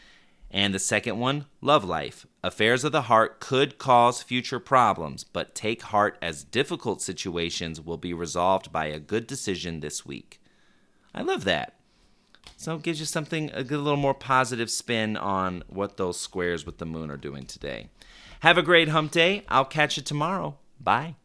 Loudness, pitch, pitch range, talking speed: -25 LUFS, 120 Hz, 90-150 Hz, 175 wpm